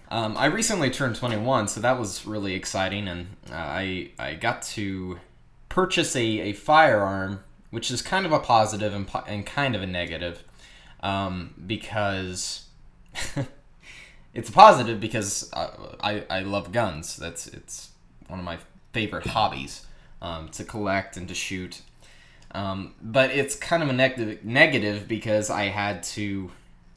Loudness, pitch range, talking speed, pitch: -25 LUFS, 90-120 Hz, 150 wpm, 100 Hz